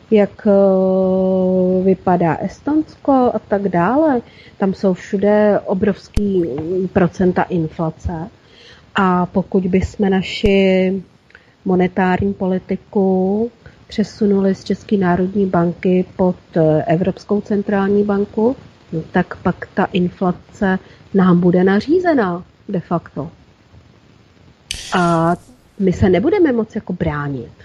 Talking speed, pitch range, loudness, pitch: 95 wpm, 180-205 Hz, -17 LUFS, 190 Hz